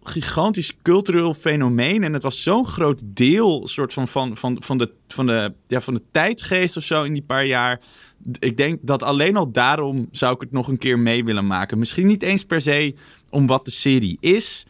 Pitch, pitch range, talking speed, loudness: 135 Hz, 125-160 Hz, 210 wpm, -20 LUFS